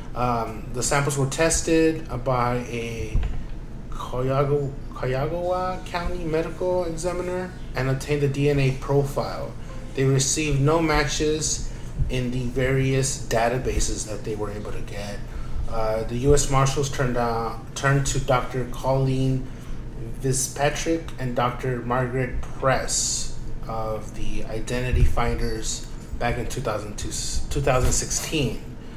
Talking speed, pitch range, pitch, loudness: 110 wpm, 120-145 Hz, 130 Hz, -25 LUFS